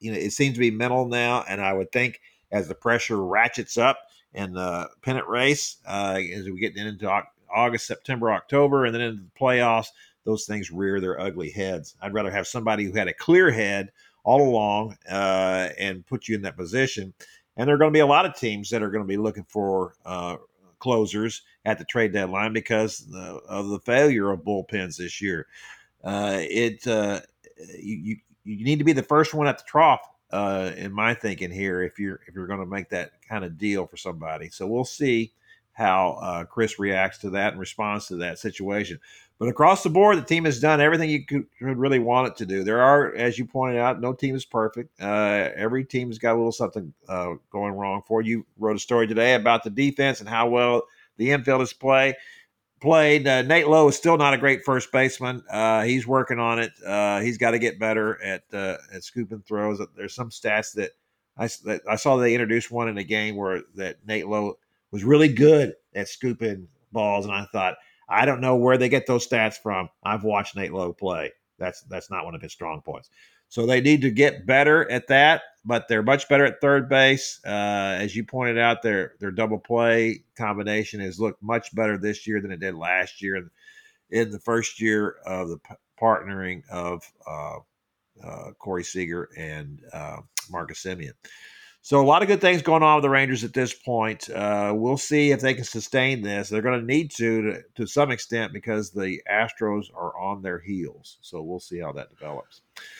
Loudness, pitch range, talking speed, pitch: -23 LUFS, 100-130 Hz, 210 wpm, 110 Hz